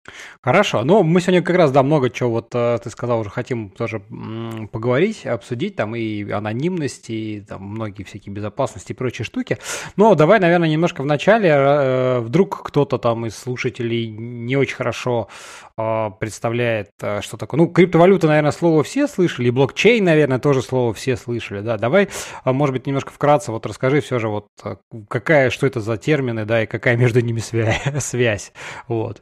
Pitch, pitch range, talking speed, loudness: 125 Hz, 115-145 Hz, 175 wpm, -19 LUFS